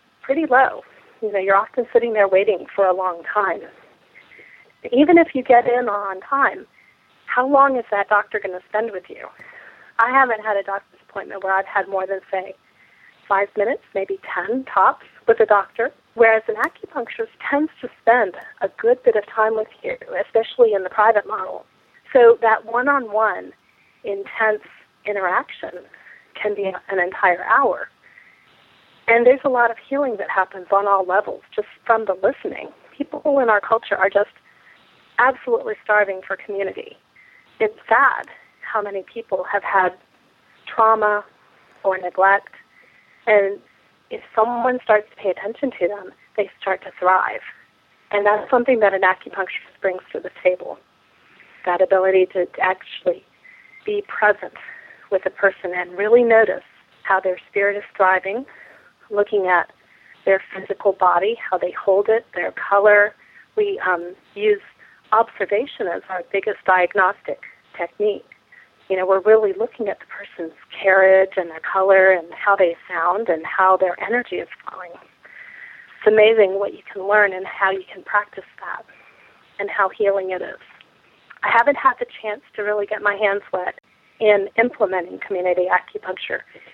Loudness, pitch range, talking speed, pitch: -19 LUFS, 190-235 Hz, 155 wpm, 205 Hz